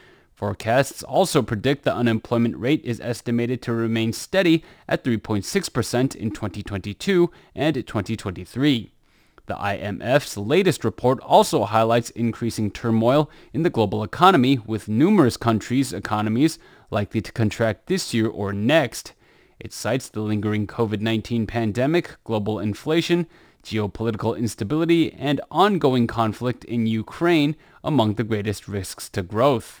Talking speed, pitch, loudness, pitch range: 125 wpm, 115 Hz, -22 LUFS, 110-145 Hz